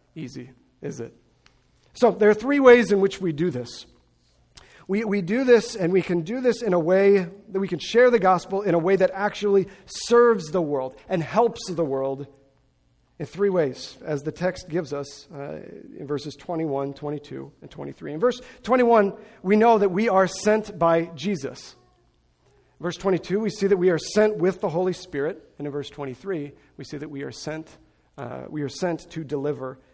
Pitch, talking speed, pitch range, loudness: 180 Hz, 195 wpm, 145-205 Hz, -23 LUFS